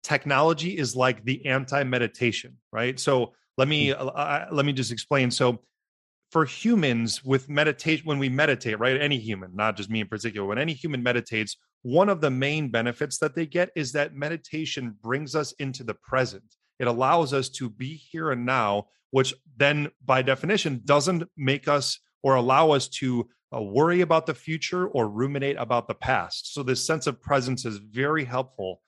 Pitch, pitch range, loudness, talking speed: 135 Hz, 125-150 Hz, -25 LUFS, 185 wpm